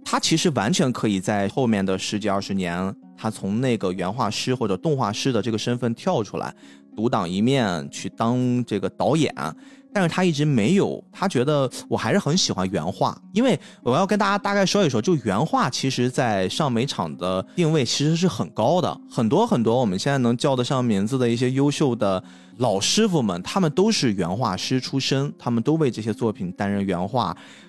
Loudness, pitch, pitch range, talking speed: -22 LUFS, 125 Hz, 100-160 Hz, 300 characters per minute